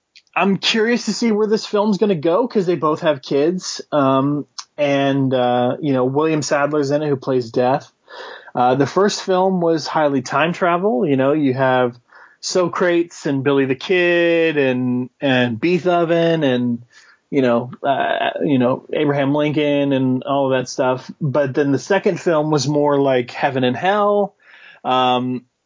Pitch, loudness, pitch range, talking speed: 145 Hz, -18 LUFS, 130-175 Hz, 170 wpm